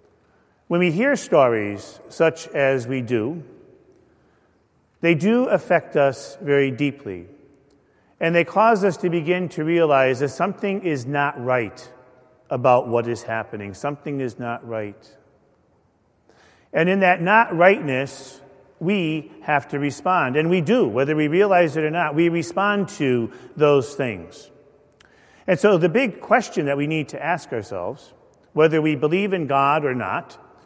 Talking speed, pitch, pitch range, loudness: 150 wpm, 145 Hz, 130-175 Hz, -20 LUFS